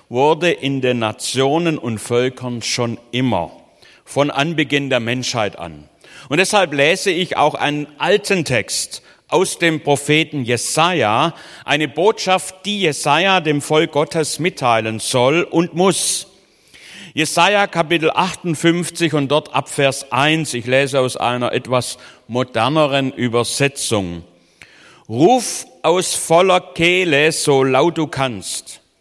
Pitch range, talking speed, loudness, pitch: 125-165 Hz, 120 wpm, -17 LUFS, 140 Hz